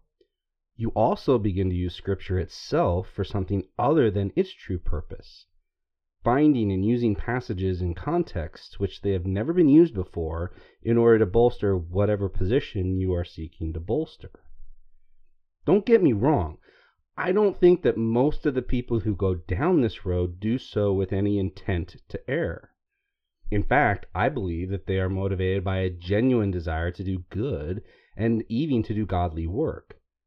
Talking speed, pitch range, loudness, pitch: 165 wpm, 90-115 Hz, -25 LUFS, 95 Hz